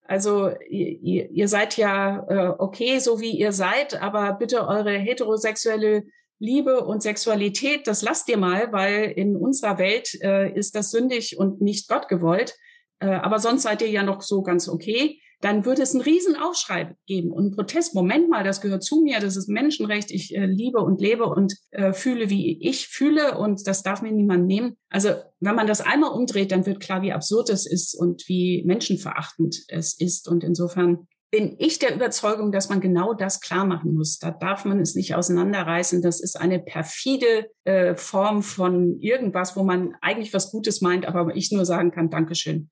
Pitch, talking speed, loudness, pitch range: 200 Hz, 190 wpm, -22 LUFS, 180-220 Hz